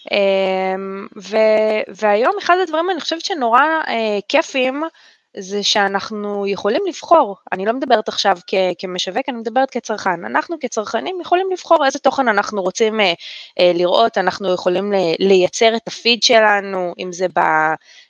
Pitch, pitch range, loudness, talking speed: 210 Hz, 190-270 Hz, -17 LUFS, 145 wpm